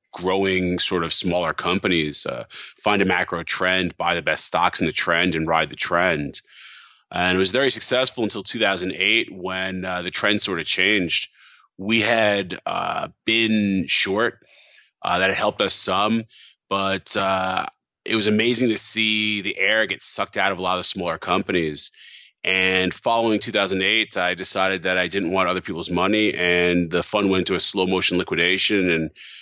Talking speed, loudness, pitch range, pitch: 175 wpm, -20 LUFS, 90-105 Hz, 95 Hz